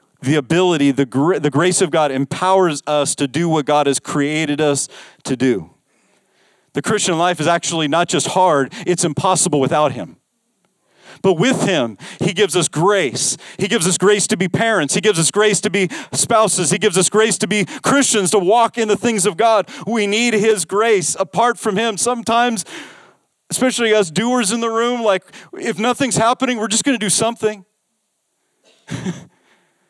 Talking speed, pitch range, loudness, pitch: 180 wpm, 165-220 Hz, -16 LUFS, 195 Hz